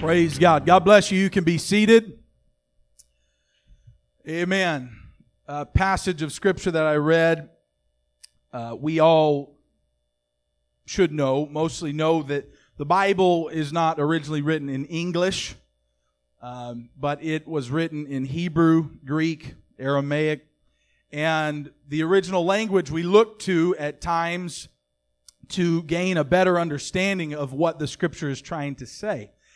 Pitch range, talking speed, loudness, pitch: 130-170 Hz, 130 wpm, -22 LUFS, 155 Hz